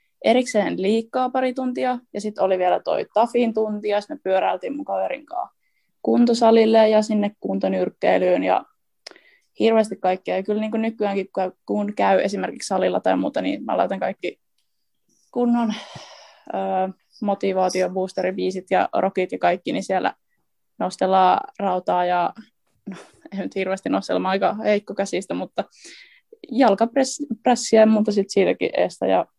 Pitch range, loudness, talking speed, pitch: 190-240 Hz, -21 LUFS, 140 wpm, 210 Hz